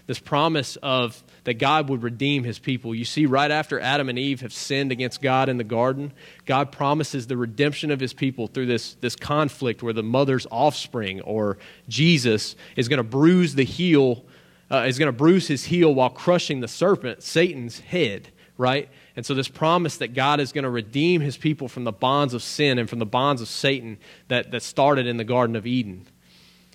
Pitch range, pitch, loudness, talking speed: 120-145 Hz, 130 Hz, -23 LUFS, 205 wpm